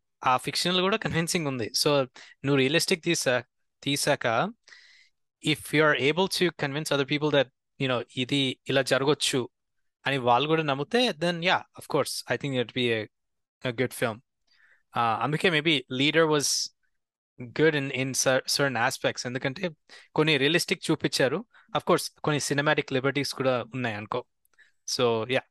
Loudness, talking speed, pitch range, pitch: -26 LUFS, 140 wpm, 130-160 Hz, 140 Hz